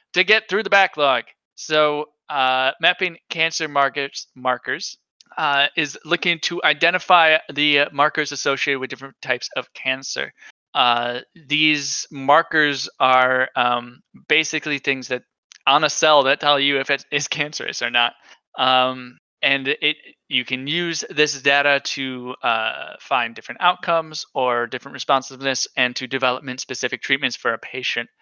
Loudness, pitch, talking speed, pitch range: -19 LUFS, 140 Hz, 145 wpm, 130-155 Hz